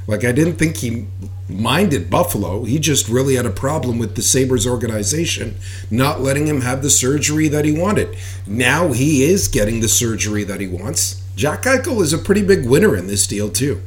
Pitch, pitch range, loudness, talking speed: 120 Hz, 100-140 Hz, -16 LUFS, 200 wpm